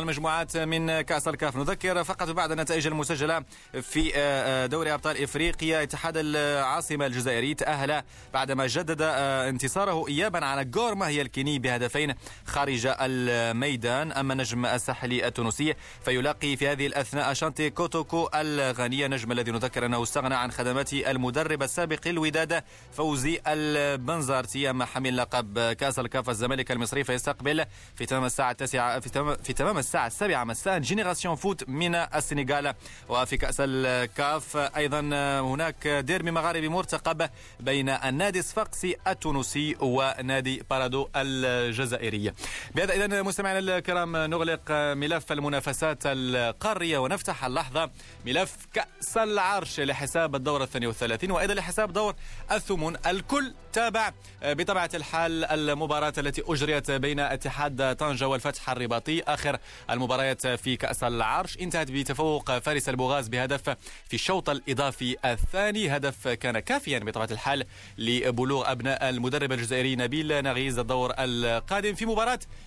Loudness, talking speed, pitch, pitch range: -28 LUFS, 125 wpm, 140 Hz, 130-160 Hz